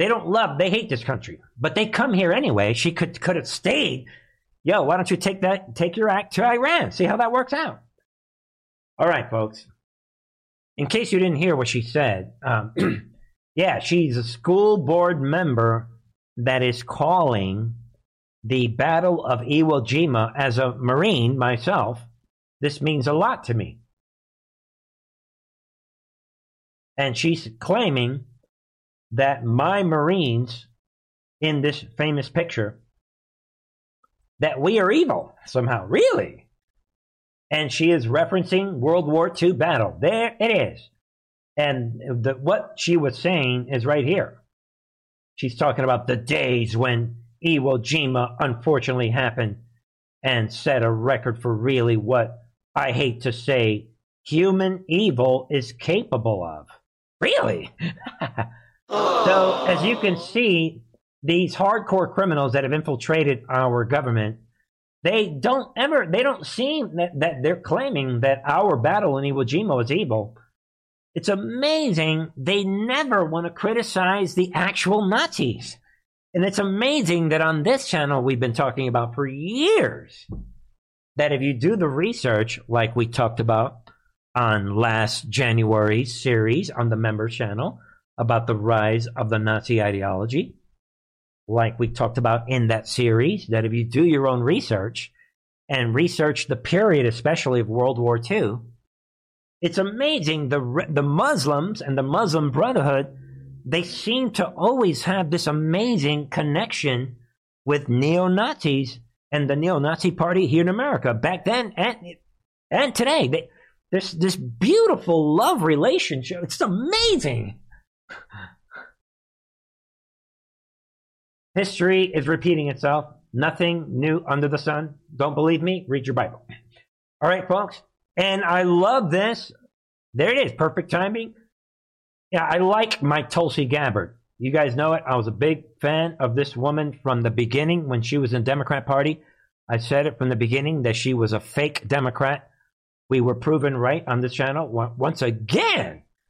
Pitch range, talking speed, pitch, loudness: 120-175 Hz, 140 wpm, 140 Hz, -22 LUFS